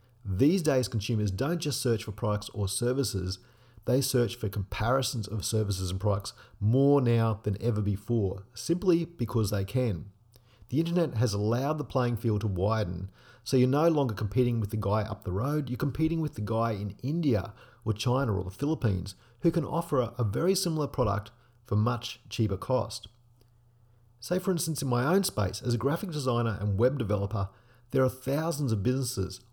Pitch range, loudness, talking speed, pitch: 105-135 Hz, -29 LUFS, 180 wpm, 120 Hz